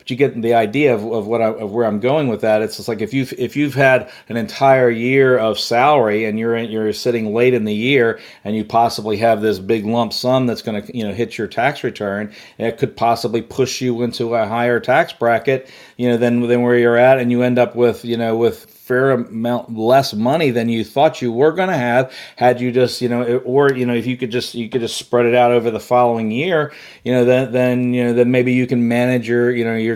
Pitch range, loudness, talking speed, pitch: 115-125 Hz, -16 LUFS, 255 wpm, 120 Hz